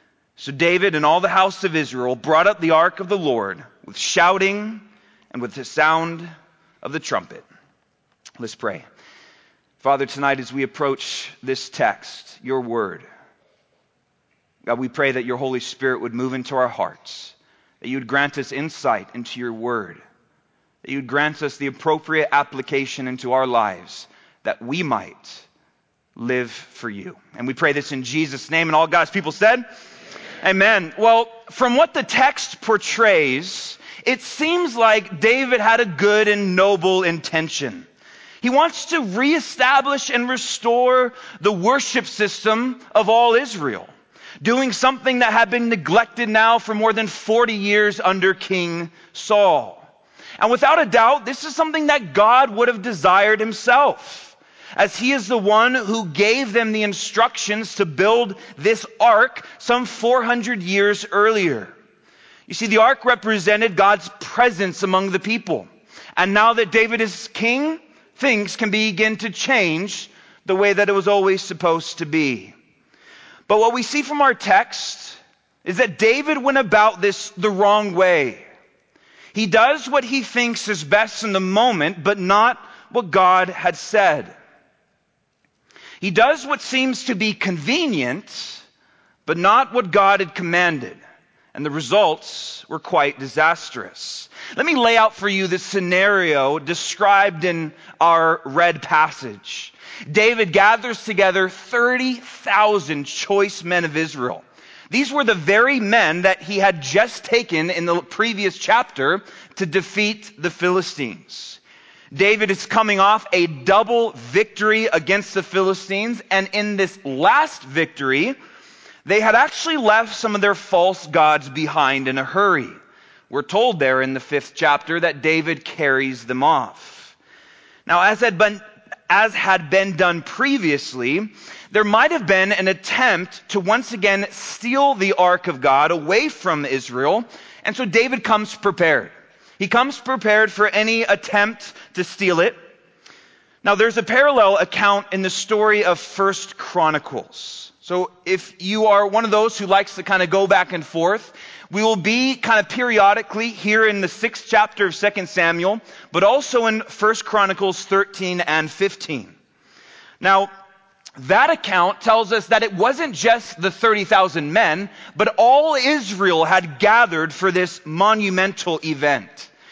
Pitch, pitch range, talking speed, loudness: 200 Hz, 170-230 Hz, 150 wpm, -18 LUFS